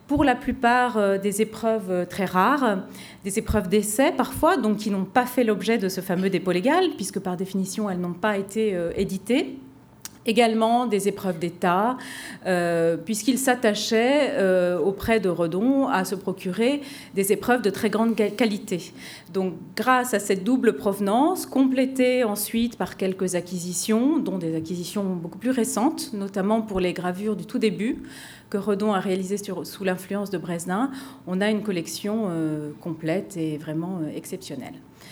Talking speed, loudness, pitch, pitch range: 160 wpm, -24 LUFS, 205 Hz, 185-235 Hz